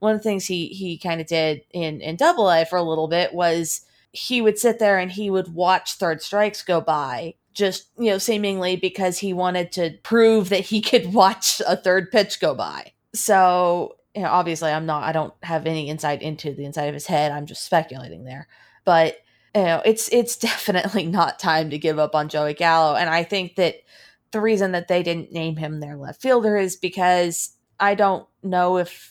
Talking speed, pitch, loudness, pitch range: 210 wpm, 180 Hz, -21 LUFS, 160-195 Hz